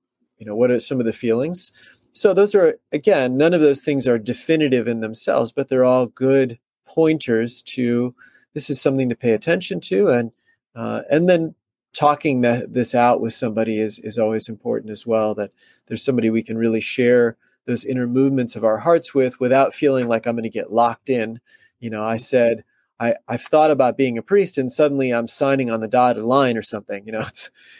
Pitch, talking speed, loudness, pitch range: 125 Hz, 205 wpm, -19 LUFS, 115-140 Hz